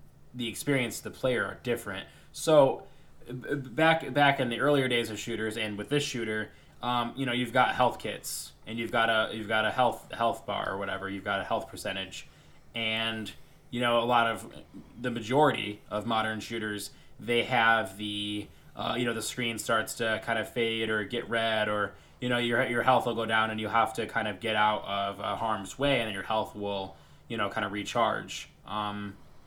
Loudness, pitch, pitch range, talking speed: -29 LUFS, 110 Hz, 105-120 Hz, 210 wpm